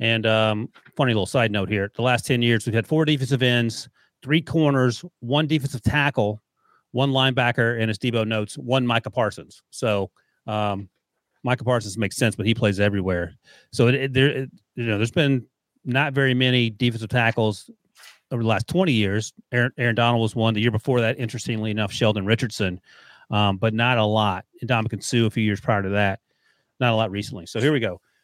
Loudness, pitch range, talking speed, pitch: -22 LUFS, 110-130 Hz, 200 wpm, 115 Hz